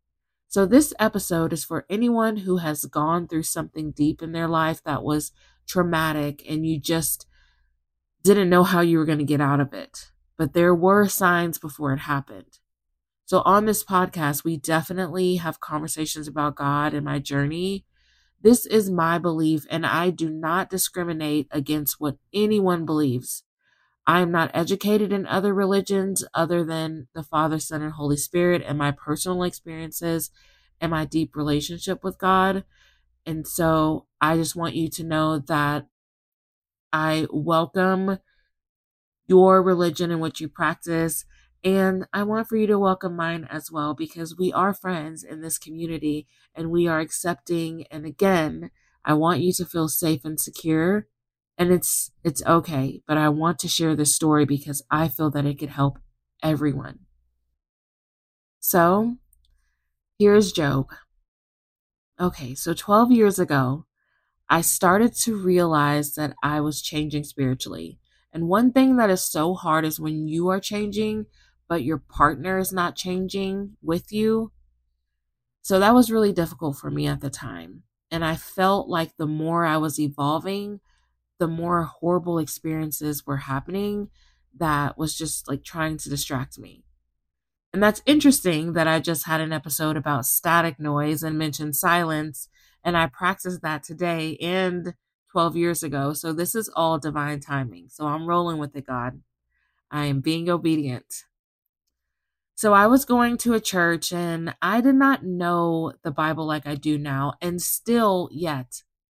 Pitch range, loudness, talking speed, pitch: 145-180 Hz, -23 LUFS, 160 wpm, 160 Hz